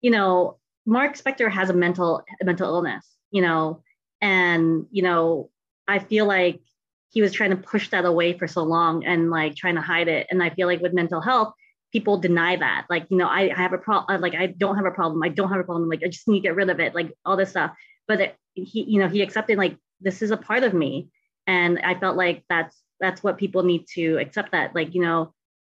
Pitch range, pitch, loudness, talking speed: 170-195 Hz, 180 Hz, -22 LUFS, 245 wpm